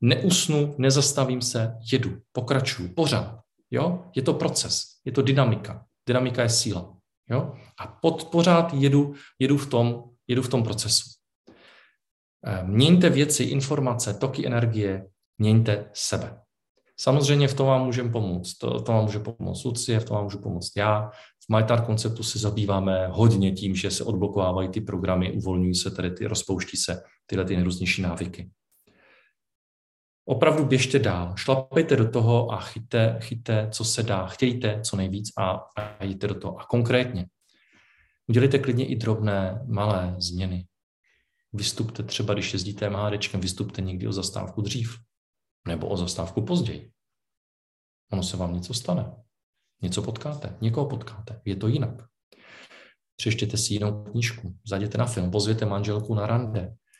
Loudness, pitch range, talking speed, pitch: -25 LUFS, 95-125 Hz, 145 wpm, 110 Hz